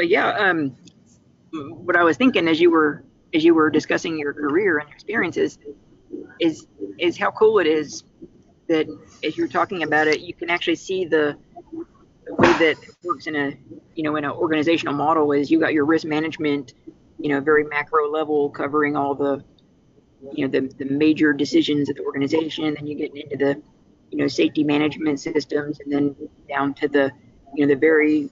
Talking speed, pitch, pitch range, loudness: 190 wpm, 150 Hz, 145-160 Hz, -21 LUFS